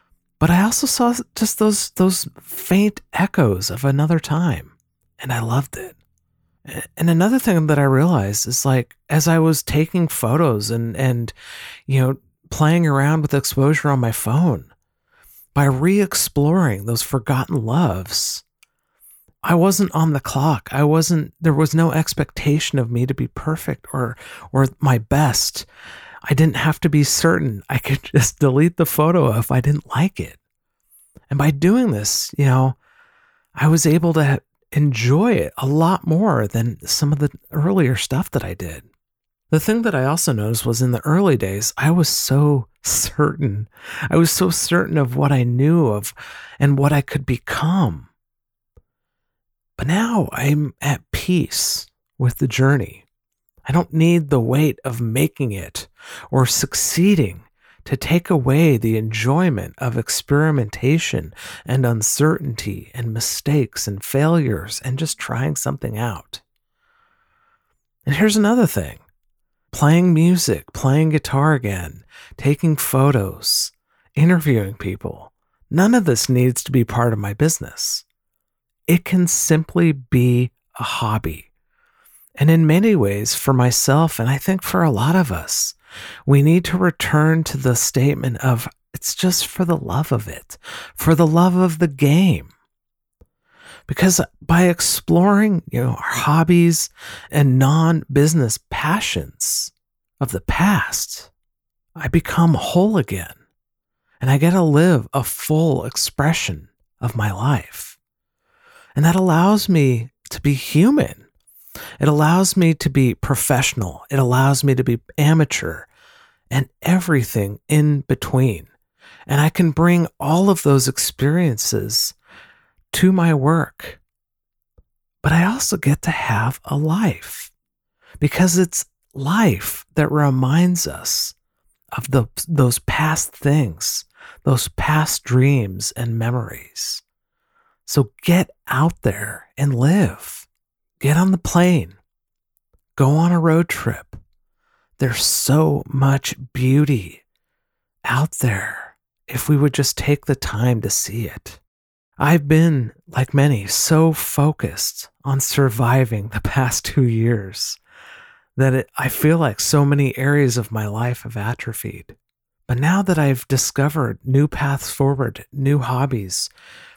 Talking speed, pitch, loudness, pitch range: 140 wpm, 140 Hz, -18 LUFS, 125-165 Hz